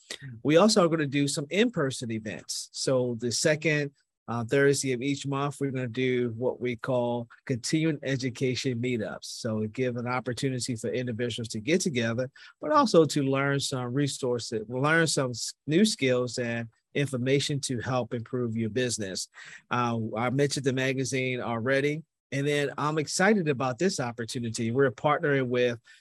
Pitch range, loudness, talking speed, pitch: 120-145 Hz, -28 LUFS, 165 wpm, 130 Hz